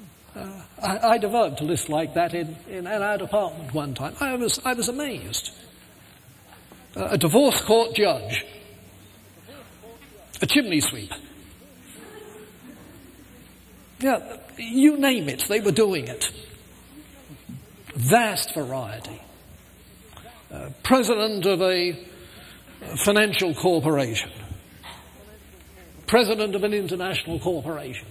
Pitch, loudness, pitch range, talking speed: 180 Hz, -23 LUFS, 130-215 Hz, 100 wpm